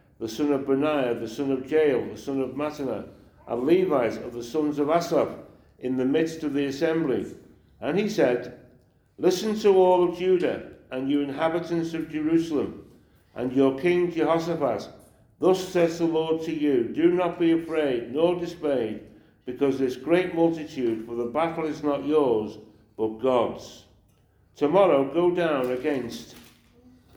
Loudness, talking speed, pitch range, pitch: -25 LUFS, 155 wpm, 125-165 Hz, 150 Hz